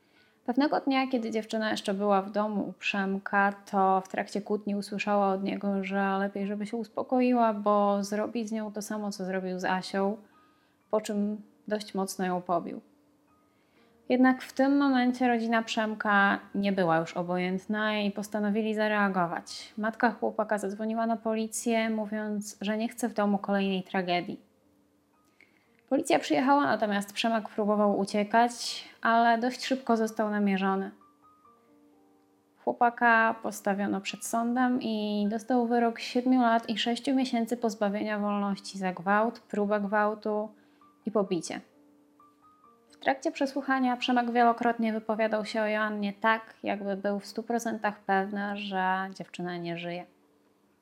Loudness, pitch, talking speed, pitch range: -29 LUFS, 215 Hz, 135 wpm, 200-235 Hz